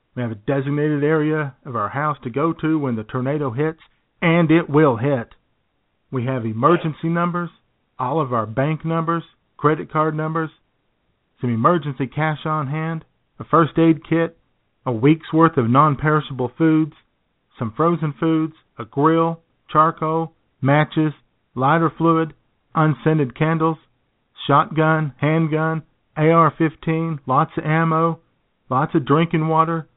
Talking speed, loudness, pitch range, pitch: 140 wpm, -19 LUFS, 135-160 Hz, 155 Hz